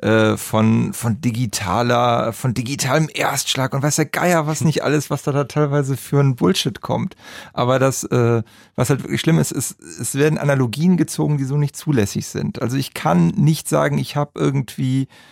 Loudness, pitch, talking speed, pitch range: -19 LUFS, 135 Hz, 180 wpm, 120-150 Hz